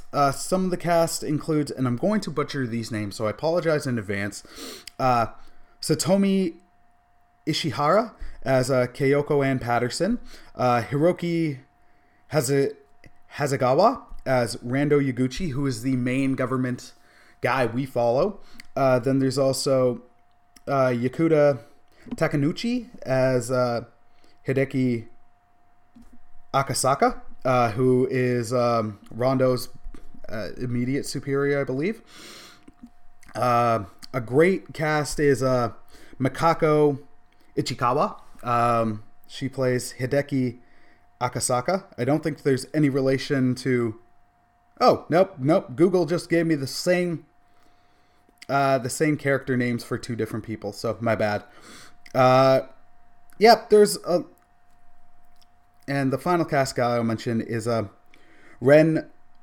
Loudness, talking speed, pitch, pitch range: -23 LUFS, 120 wpm, 130 Hz, 120-150 Hz